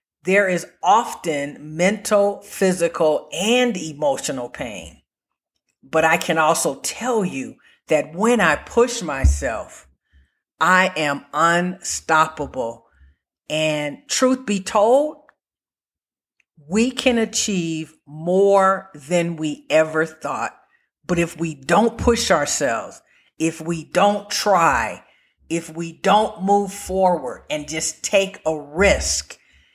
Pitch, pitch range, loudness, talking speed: 170 Hz, 155-200 Hz, -20 LUFS, 110 wpm